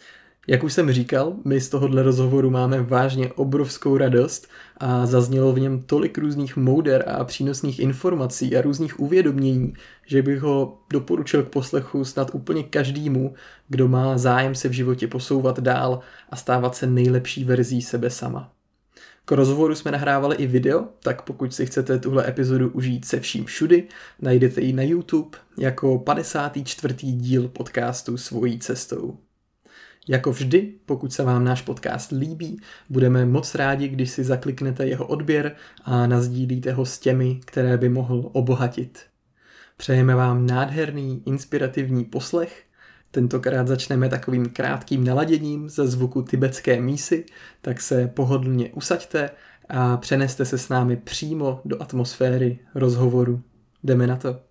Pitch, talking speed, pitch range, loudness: 130 Hz, 145 wpm, 125-140 Hz, -22 LUFS